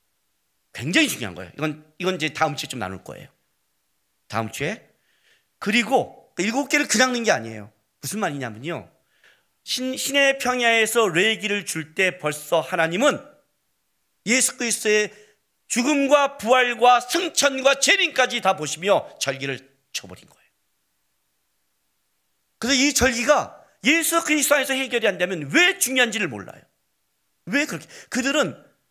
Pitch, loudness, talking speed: 205 Hz, -21 LUFS, 290 characters per minute